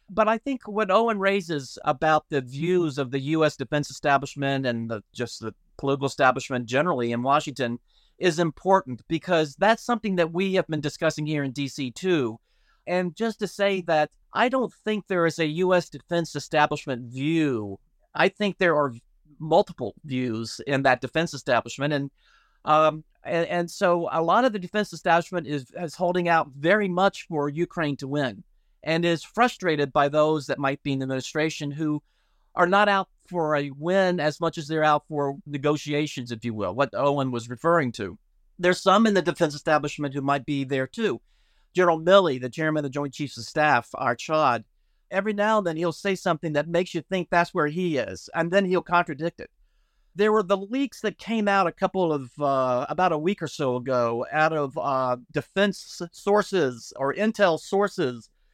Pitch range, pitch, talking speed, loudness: 140-180 Hz, 155 Hz, 190 wpm, -25 LUFS